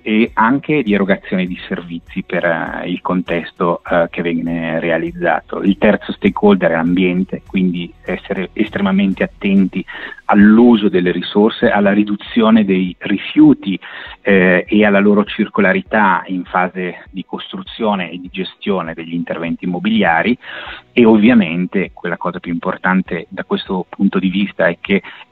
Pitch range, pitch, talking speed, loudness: 90-105 Hz, 95 Hz, 135 wpm, -15 LUFS